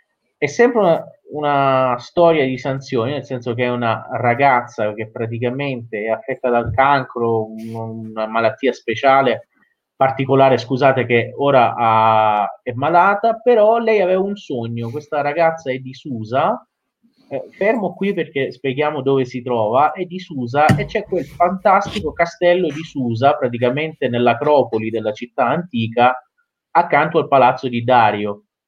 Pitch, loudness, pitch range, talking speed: 130 Hz, -17 LUFS, 120-160 Hz, 140 wpm